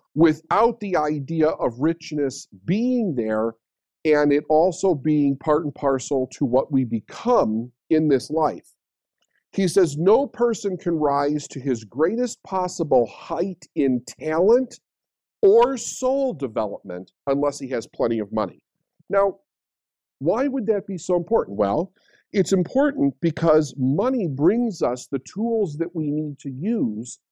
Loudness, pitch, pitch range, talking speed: -22 LUFS, 155 Hz, 135-195 Hz, 140 wpm